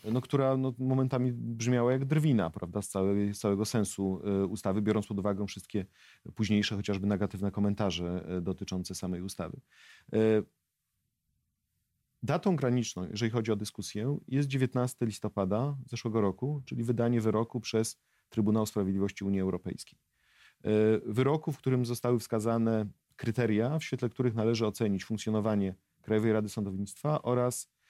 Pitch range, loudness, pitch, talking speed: 100-125 Hz, -31 LUFS, 110 Hz, 130 wpm